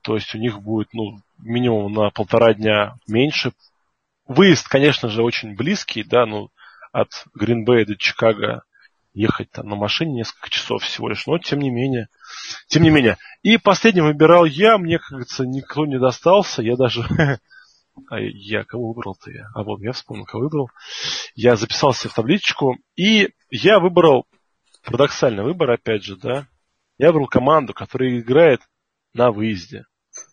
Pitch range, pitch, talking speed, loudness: 110-150 Hz, 125 Hz, 155 wpm, -18 LUFS